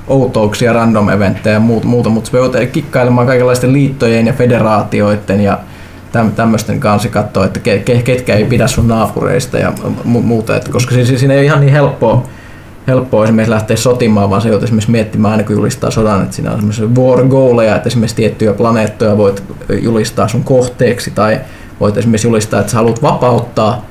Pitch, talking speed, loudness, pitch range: 115 Hz, 165 wpm, -11 LUFS, 105-125 Hz